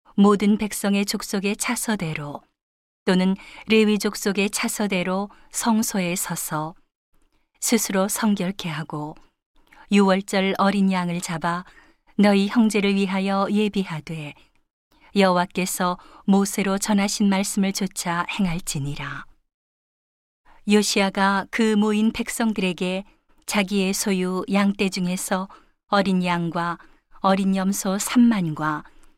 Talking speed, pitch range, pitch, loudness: 225 characters per minute, 185-210 Hz, 195 Hz, -22 LUFS